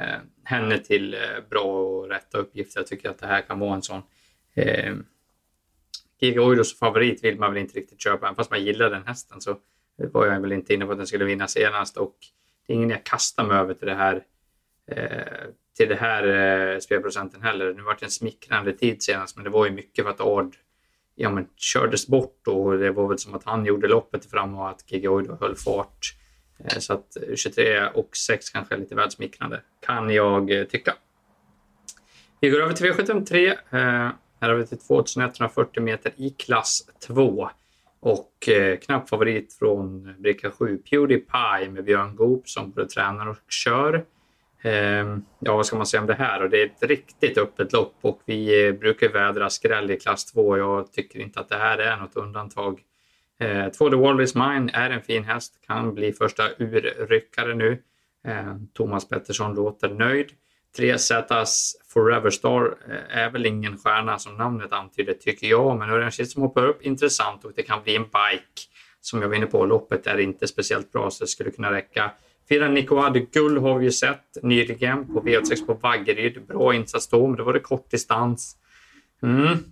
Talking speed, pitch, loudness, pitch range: 190 wpm, 115 Hz, -23 LUFS, 100-140 Hz